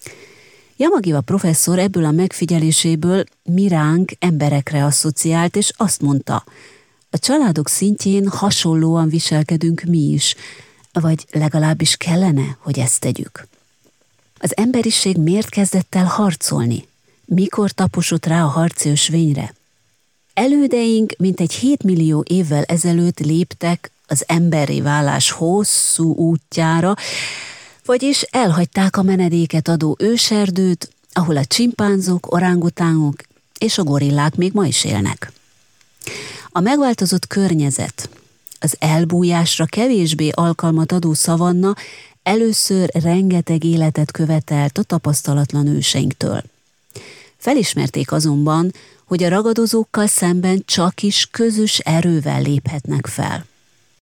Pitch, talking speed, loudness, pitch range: 170 Hz, 105 wpm, -16 LUFS, 155-190 Hz